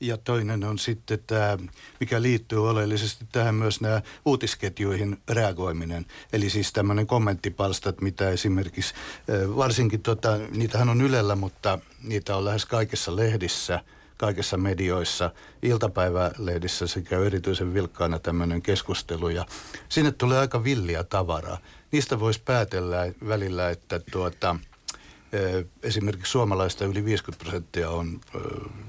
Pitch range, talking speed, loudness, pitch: 90-110 Hz, 115 wpm, -26 LUFS, 100 Hz